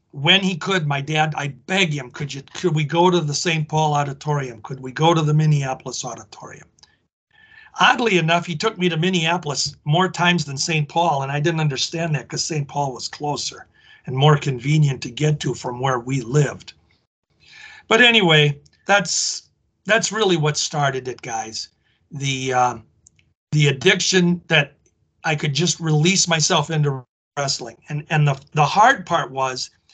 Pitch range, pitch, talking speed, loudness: 140-170 Hz, 150 Hz, 170 wpm, -19 LUFS